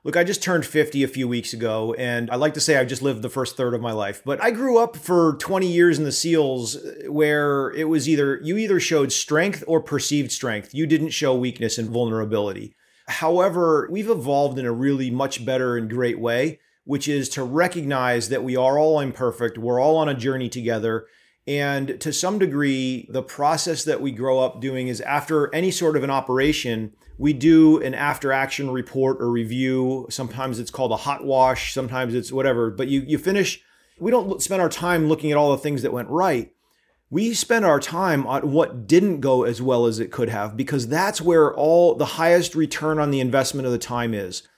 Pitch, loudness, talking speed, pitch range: 140 Hz, -21 LUFS, 210 wpm, 125-160 Hz